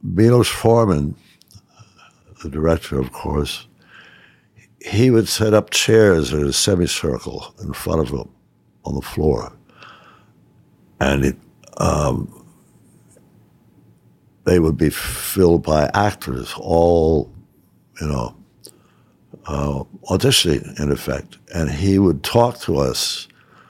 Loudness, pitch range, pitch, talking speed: -18 LUFS, 70-95 Hz, 80 Hz, 110 wpm